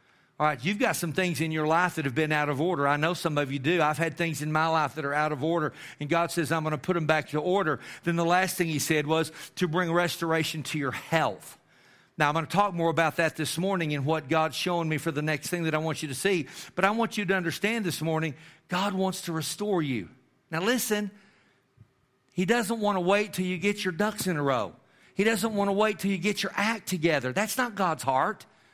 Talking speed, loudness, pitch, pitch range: 260 wpm, -27 LUFS, 165 Hz, 155-190 Hz